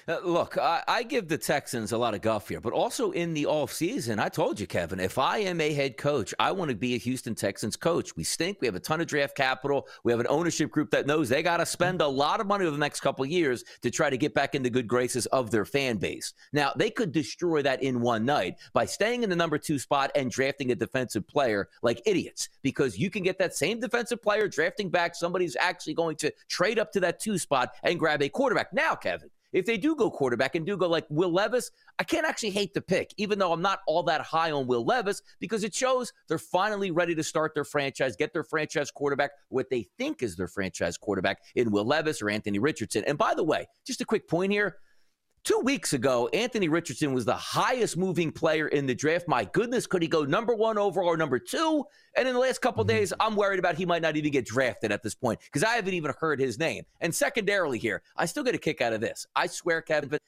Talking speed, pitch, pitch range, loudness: 255 wpm, 160 Hz, 135-200 Hz, -28 LUFS